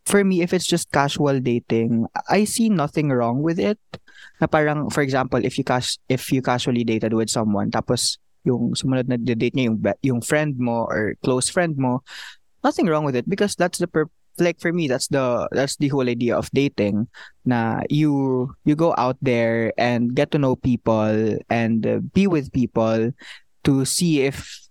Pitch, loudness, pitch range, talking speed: 130 Hz, -21 LUFS, 120-150 Hz, 185 wpm